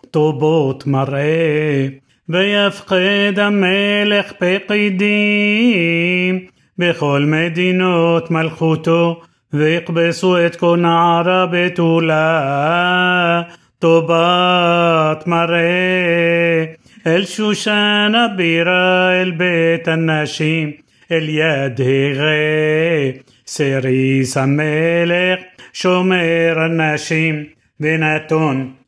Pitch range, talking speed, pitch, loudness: 155-180 Hz, 50 wpm, 170 Hz, -15 LUFS